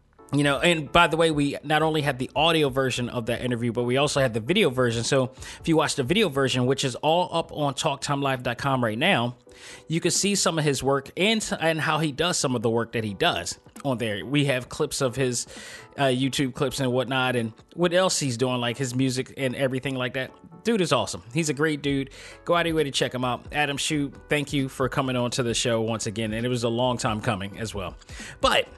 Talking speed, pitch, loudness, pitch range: 250 wpm, 135 Hz, -24 LUFS, 125-150 Hz